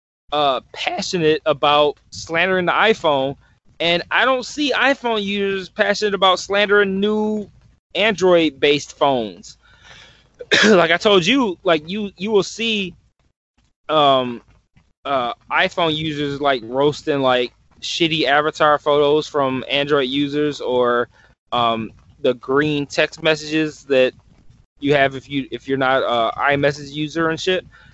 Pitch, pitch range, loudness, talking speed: 155 Hz, 140-190 Hz, -18 LUFS, 130 wpm